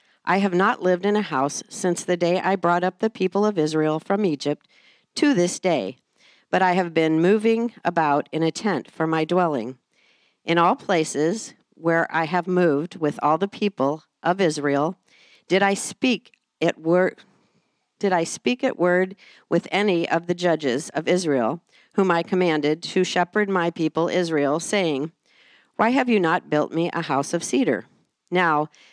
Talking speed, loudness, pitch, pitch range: 175 wpm, -22 LUFS, 175 Hz, 160-195 Hz